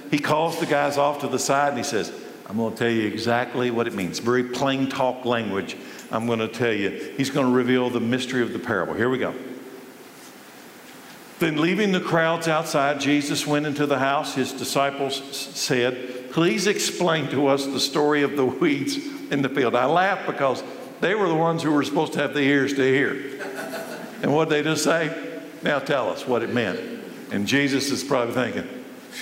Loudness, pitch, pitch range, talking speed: -23 LUFS, 140 Hz, 125-150 Hz, 205 wpm